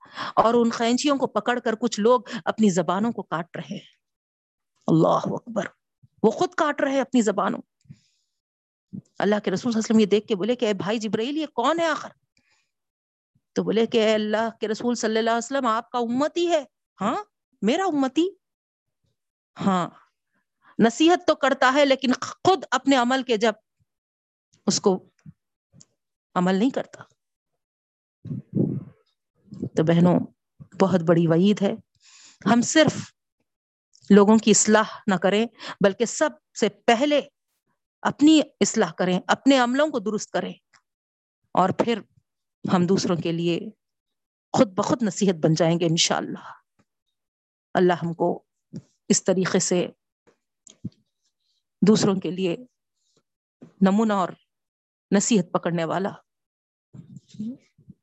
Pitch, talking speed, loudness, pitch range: 220 Hz, 135 wpm, -22 LUFS, 190-250 Hz